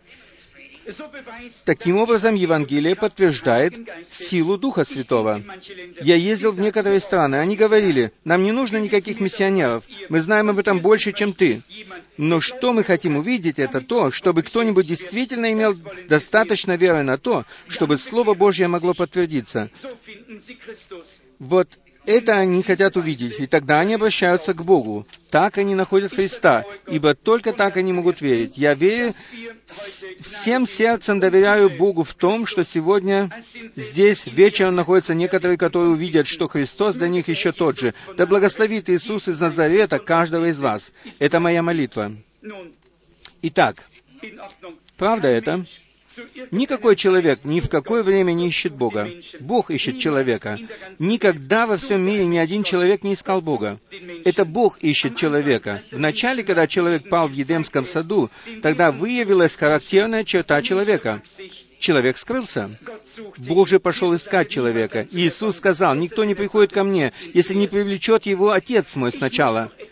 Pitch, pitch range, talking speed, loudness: 185 Hz, 160-205 Hz, 140 wpm, -19 LUFS